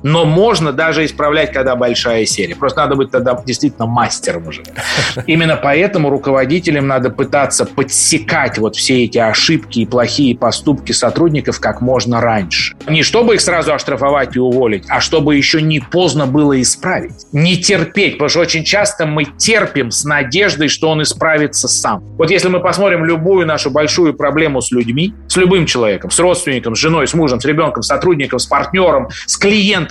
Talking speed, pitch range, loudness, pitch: 175 wpm, 130-165 Hz, -12 LUFS, 150 Hz